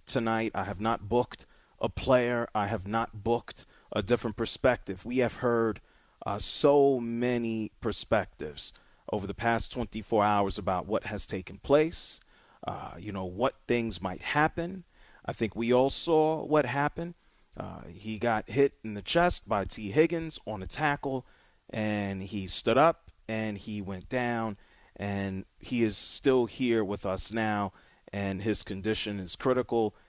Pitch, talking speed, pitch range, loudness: 115 Hz, 160 wpm, 100-125 Hz, -30 LUFS